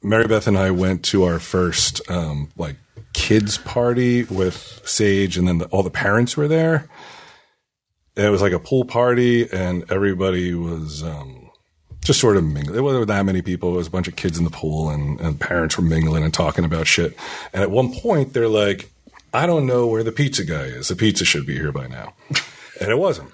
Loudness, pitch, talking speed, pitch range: -19 LUFS, 95 Hz, 215 wpm, 85-115 Hz